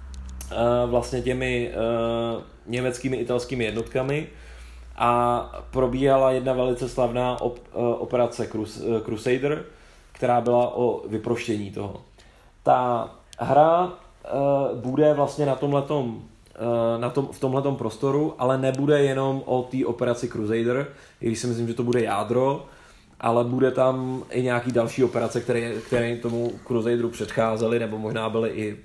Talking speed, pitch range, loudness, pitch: 130 wpm, 115-130 Hz, -24 LUFS, 120 Hz